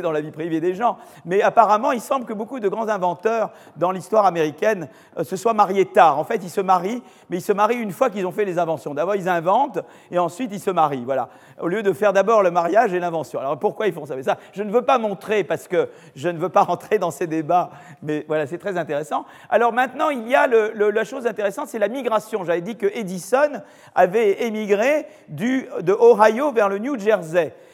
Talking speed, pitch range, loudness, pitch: 235 wpm, 175-230 Hz, -20 LUFS, 205 Hz